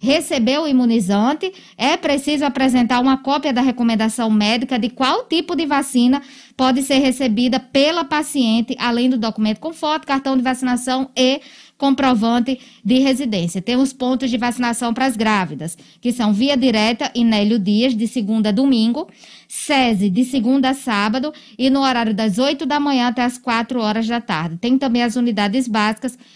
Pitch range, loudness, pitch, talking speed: 230-270 Hz, -18 LUFS, 250 Hz, 170 wpm